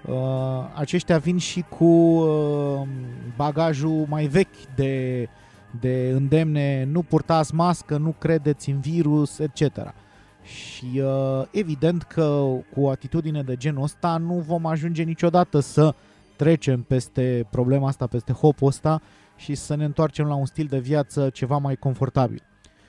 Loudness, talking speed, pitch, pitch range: -23 LUFS, 140 wpm, 145 Hz, 130-160 Hz